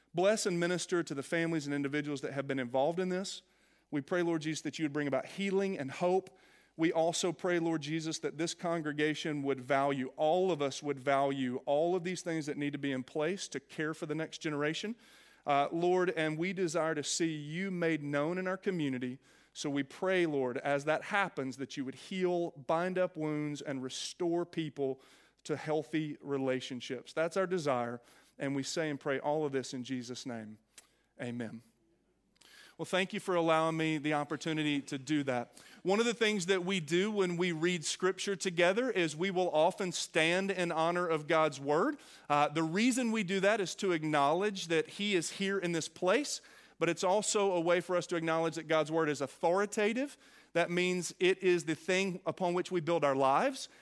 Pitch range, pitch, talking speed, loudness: 145-185 Hz, 160 Hz, 200 wpm, -33 LUFS